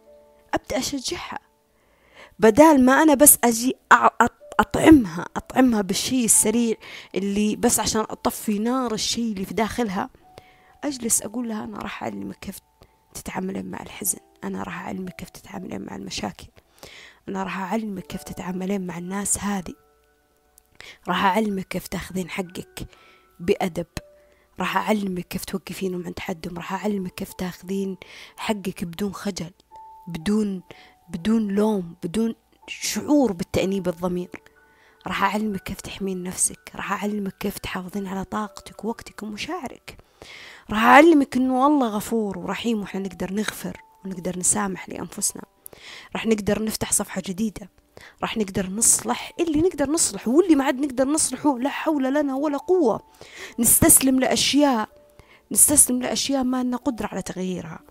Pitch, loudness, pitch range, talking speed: 205 Hz, -22 LUFS, 185-245 Hz, 130 wpm